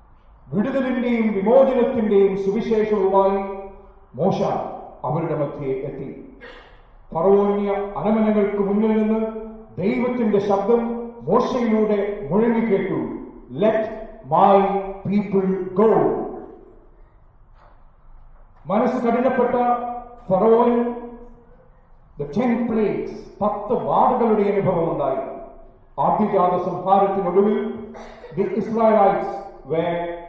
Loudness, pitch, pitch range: -20 LUFS, 210 Hz, 195-235 Hz